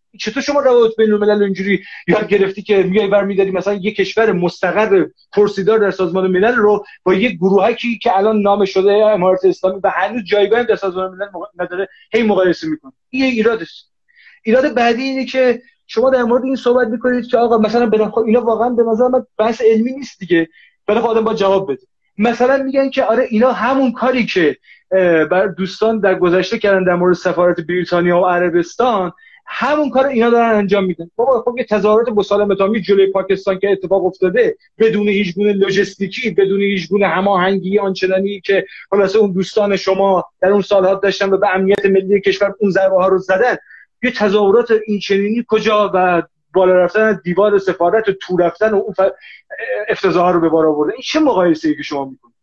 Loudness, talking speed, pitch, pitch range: -15 LUFS, 185 wpm, 200 Hz, 190-230 Hz